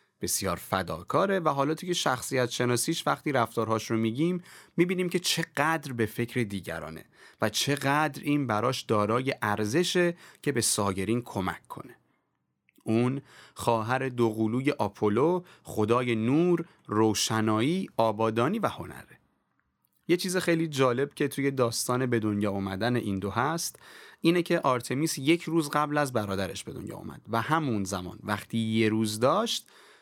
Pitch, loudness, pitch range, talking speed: 125 Hz, -28 LUFS, 110-160 Hz, 140 wpm